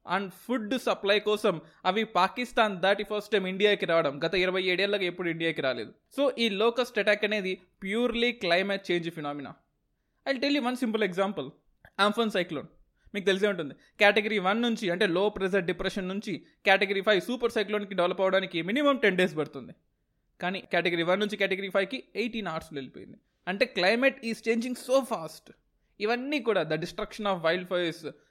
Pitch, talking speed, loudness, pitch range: 200 Hz, 160 wpm, -28 LUFS, 180-225 Hz